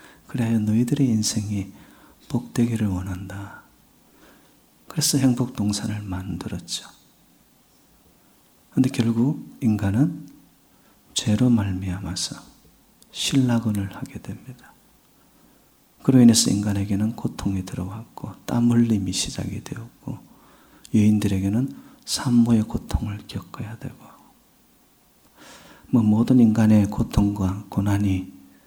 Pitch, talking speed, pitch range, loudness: 110 Hz, 230 characters per minute, 100-120 Hz, -22 LUFS